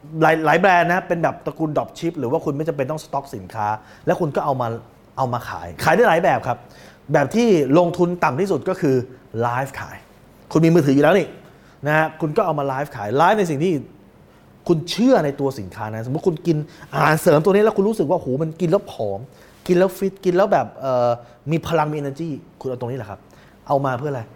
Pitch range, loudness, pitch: 130-175 Hz, -20 LUFS, 155 Hz